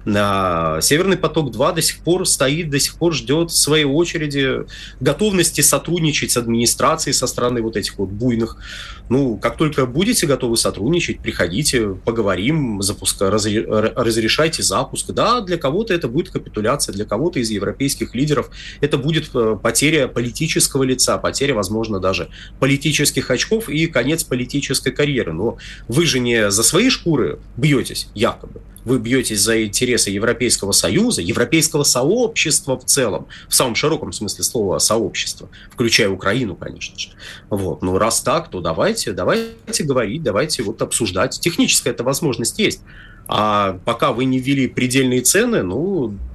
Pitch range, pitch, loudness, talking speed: 110-155 Hz, 130 Hz, -17 LUFS, 145 wpm